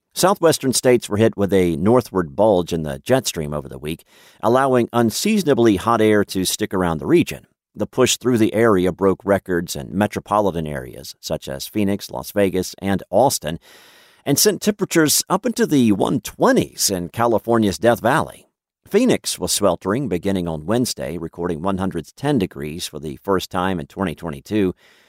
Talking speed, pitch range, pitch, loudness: 160 wpm, 85-115 Hz, 100 Hz, -19 LUFS